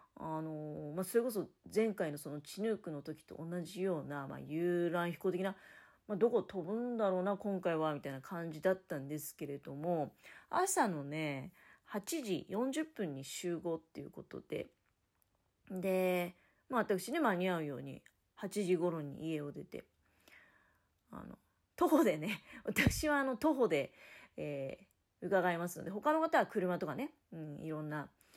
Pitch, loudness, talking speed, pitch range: 175 Hz, -37 LUFS, 285 characters per minute, 155-205 Hz